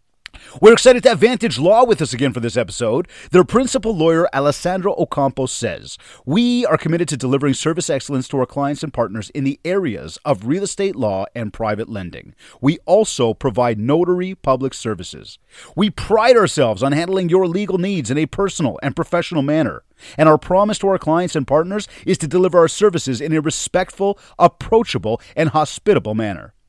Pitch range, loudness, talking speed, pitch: 130-185 Hz, -17 LUFS, 180 wpm, 155 Hz